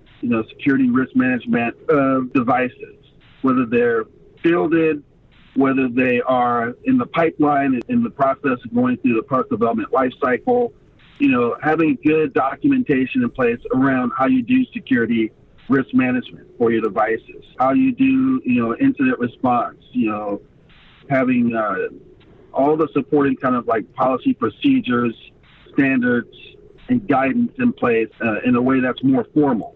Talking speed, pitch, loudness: 150 wpm, 140 Hz, -19 LUFS